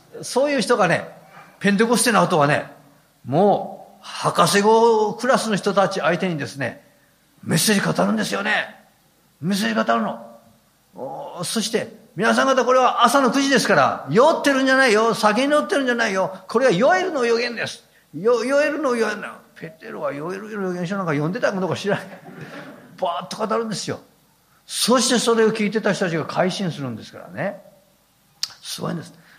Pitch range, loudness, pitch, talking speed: 180-240 Hz, -20 LUFS, 200 Hz, 355 characters per minute